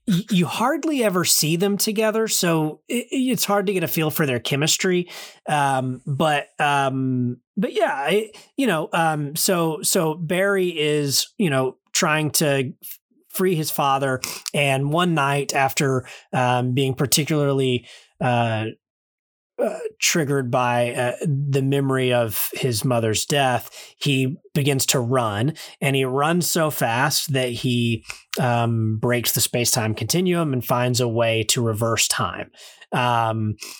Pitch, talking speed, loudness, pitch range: 140 Hz, 140 wpm, -21 LUFS, 125-175 Hz